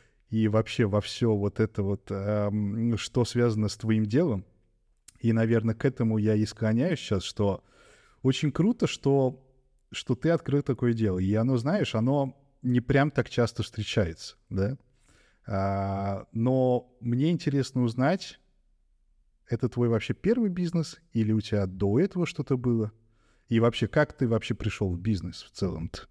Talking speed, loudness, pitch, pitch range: 150 wpm, -28 LUFS, 115 Hz, 105-130 Hz